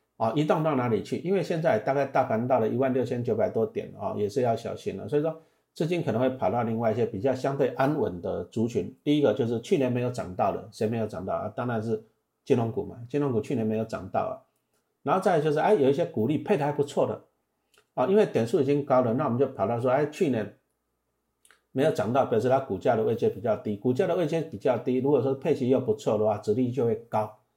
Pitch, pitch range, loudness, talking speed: 125 Hz, 110-145 Hz, -27 LUFS, 360 characters per minute